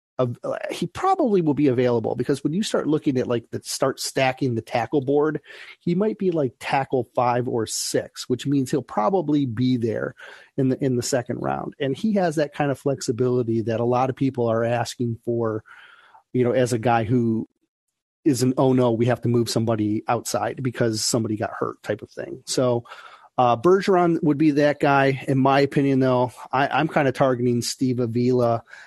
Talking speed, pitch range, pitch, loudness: 195 wpm, 120-145 Hz, 130 Hz, -22 LUFS